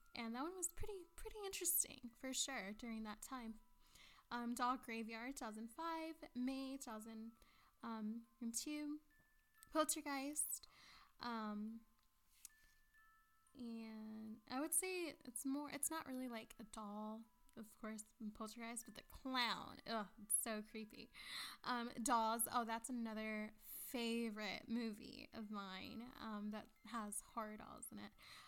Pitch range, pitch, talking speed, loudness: 220-275 Hz, 235 Hz, 120 wpm, -47 LUFS